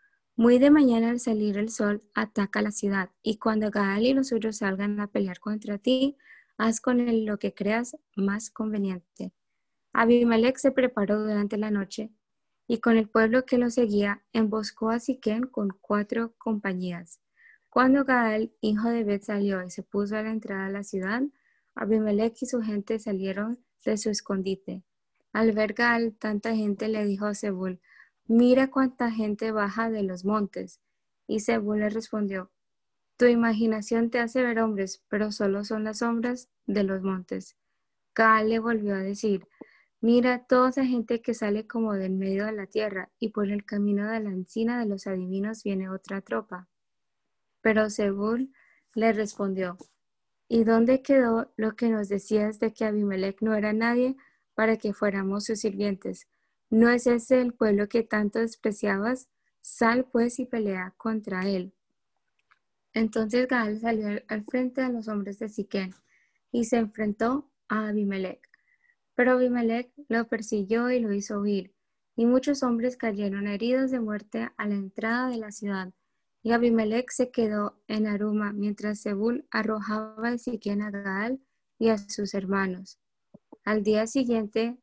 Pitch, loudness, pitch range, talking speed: 220 Hz, -27 LUFS, 205-235 Hz, 160 wpm